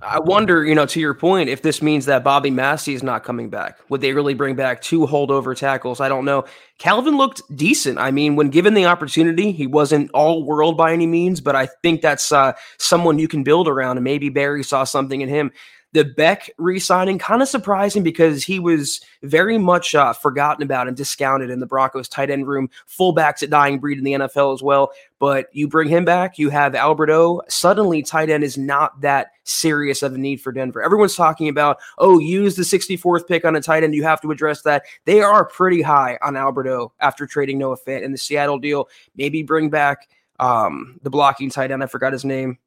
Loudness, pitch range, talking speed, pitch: -17 LUFS, 135-165 Hz, 220 wpm, 145 Hz